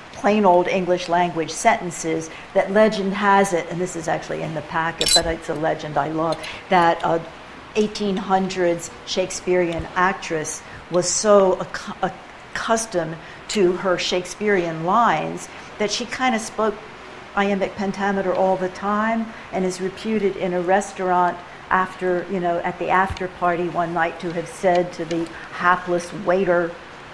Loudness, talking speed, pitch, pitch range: -21 LUFS, 145 wpm, 180 Hz, 170-195 Hz